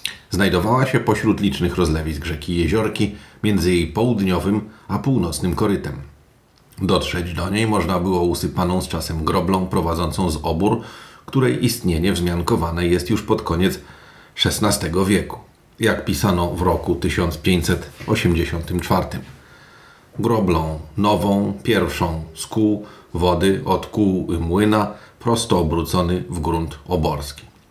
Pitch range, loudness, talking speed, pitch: 85-105 Hz, -20 LUFS, 115 wpm, 90 Hz